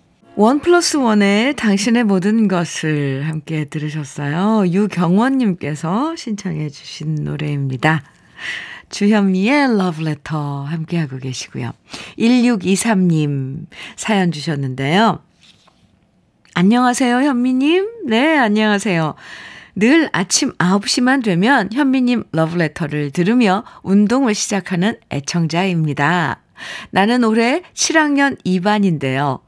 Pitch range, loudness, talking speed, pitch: 155-235 Hz, -16 LUFS, 235 characters per minute, 195 Hz